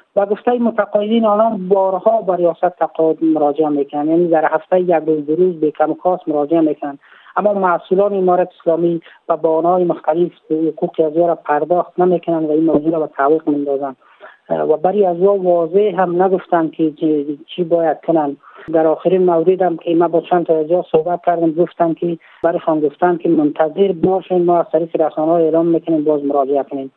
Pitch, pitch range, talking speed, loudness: 165 Hz, 155-180 Hz, 175 wpm, -16 LUFS